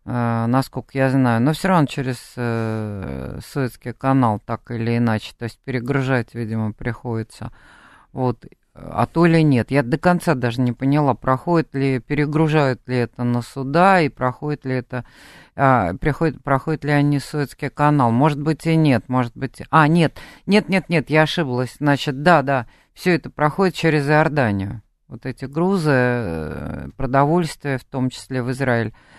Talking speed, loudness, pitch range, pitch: 160 wpm, -20 LUFS, 120-150 Hz, 135 Hz